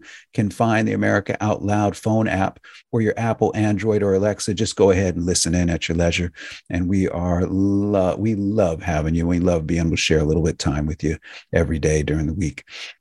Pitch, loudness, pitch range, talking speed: 95 Hz, -20 LUFS, 85-105 Hz, 225 wpm